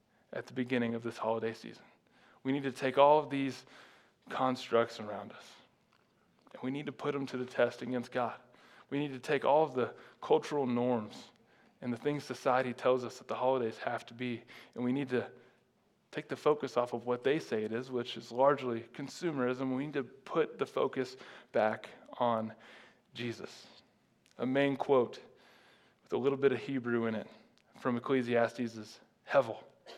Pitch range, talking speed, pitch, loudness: 120-135 Hz, 180 wpm, 125 Hz, -34 LUFS